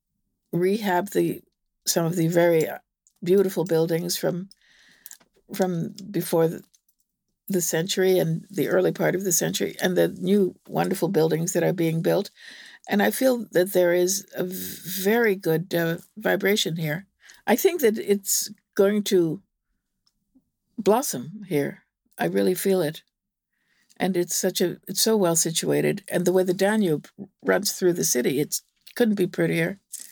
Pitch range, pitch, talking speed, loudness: 170-200 Hz, 185 Hz, 150 wpm, -23 LUFS